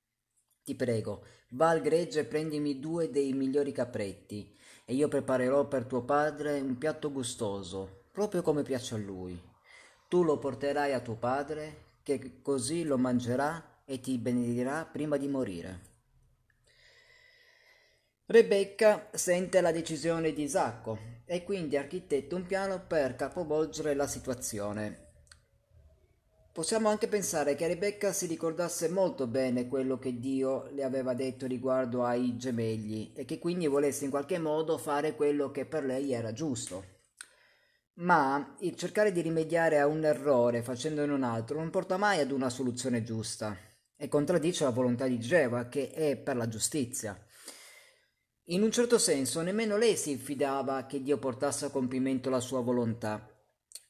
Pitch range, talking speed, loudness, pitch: 125-160 Hz, 150 wpm, -31 LUFS, 140 Hz